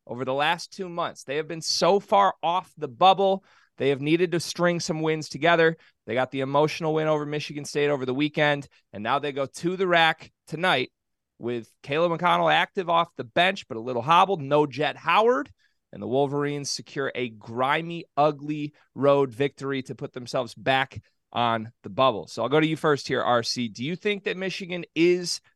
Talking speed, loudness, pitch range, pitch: 195 wpm, -25 LUFS, 130-170 Hz, 150 Hz